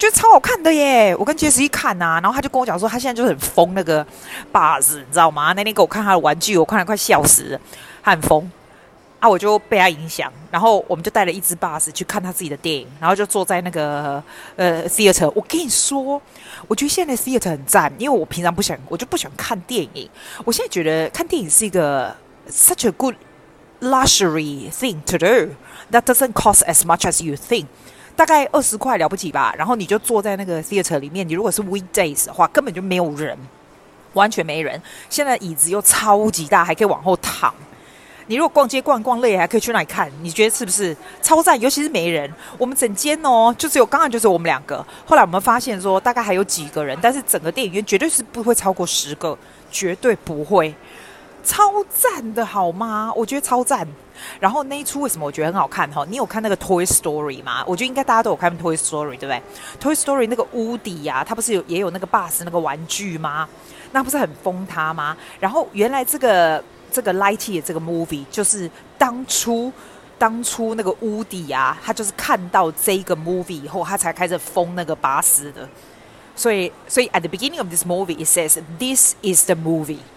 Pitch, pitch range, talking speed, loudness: 195 Hz, 170-240 Hz, 405 characters per minute, -17 LUFS